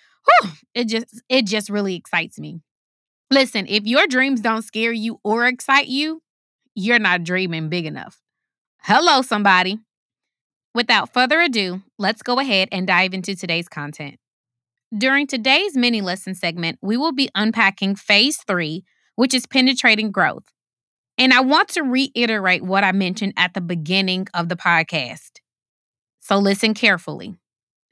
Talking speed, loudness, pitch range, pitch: 145 wpm, -18 LUFS, 185-250 Hz, 210 Hz